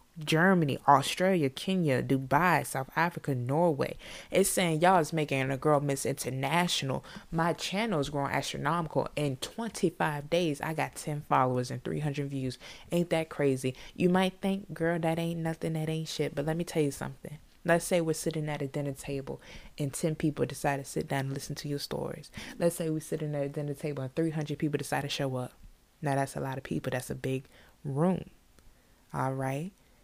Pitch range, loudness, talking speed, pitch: 140-165 Hz, -31 LUFS, 195 wpm, 150 Hz